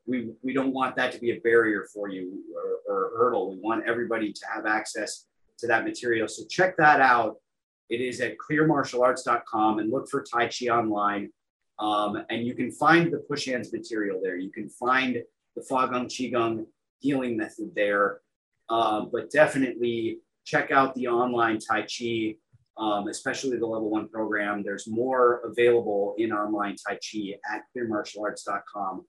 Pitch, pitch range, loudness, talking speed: 120 Hz, 110-130 Hz, -26 LUFS, 170 wpm